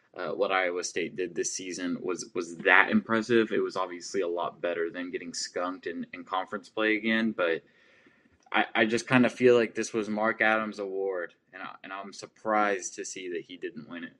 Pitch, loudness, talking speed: 115 Hz, -28 LUFS, 210 wpm